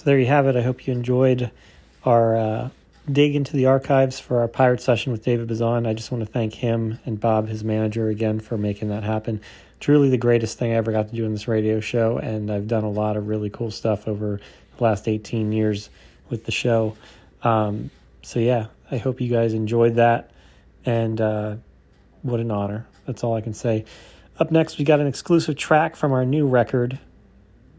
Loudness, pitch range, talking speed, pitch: -22 LUFS, 110-125 Hz, 210 wpm, 115 Hz